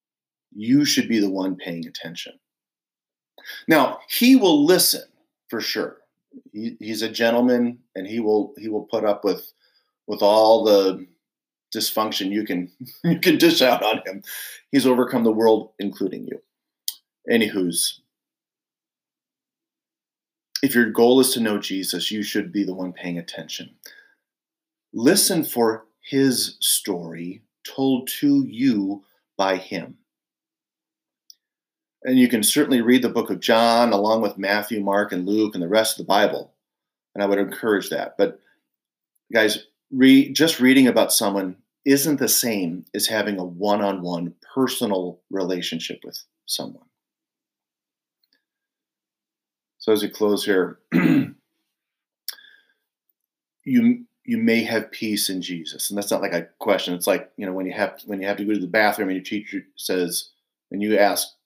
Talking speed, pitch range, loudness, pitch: 145 wpm, 100-140 Hz, -20 LUFS, 110 Hz